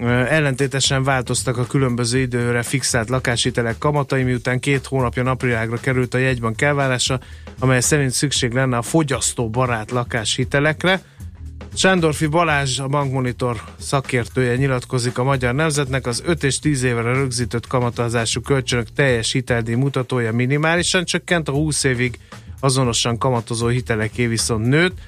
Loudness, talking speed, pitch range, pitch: -19 LUFS, 130 wpm, 120-140 Hz, 130 Hz